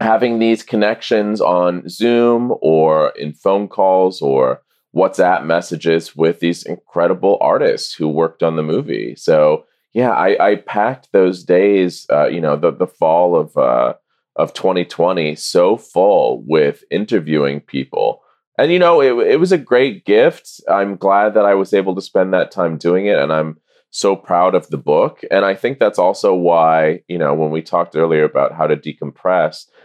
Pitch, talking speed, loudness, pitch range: 95 Hz, 175 wpm, -15 LUFS, 80-115 Hz